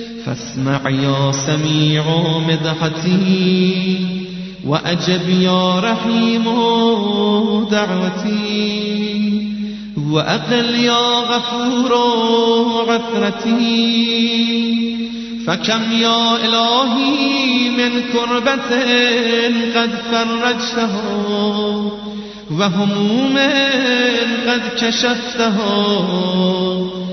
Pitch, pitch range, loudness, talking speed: 225 Hz, 185-235 Hz, -15 LUFS, 50 wpm